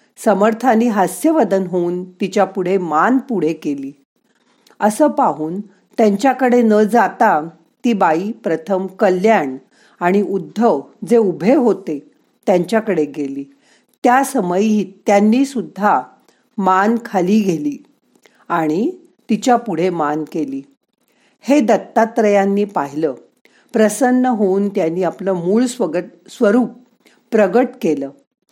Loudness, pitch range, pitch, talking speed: -16 LUFS, 180-235 Hz, 205 Hz, 100 wpm